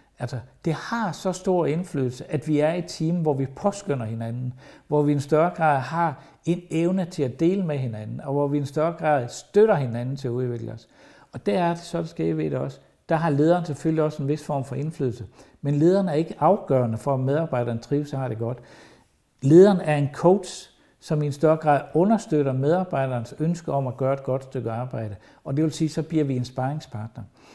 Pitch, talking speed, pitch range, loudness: 145 Hz, 230 wpm, 130-165 Hz, -24 LUFS